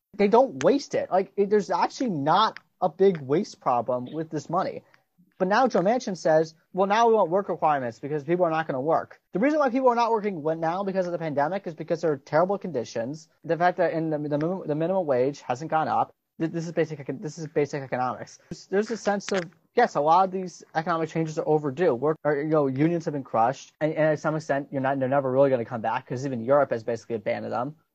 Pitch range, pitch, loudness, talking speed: 145-190 Hz, 160 Hz, -25 LUFS, 235 wpm